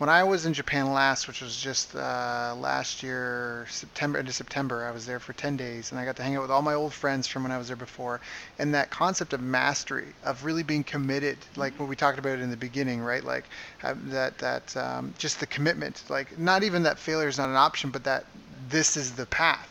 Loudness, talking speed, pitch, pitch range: -28 LUFS, 240 wpm, 135 Hz, 125-145 Hz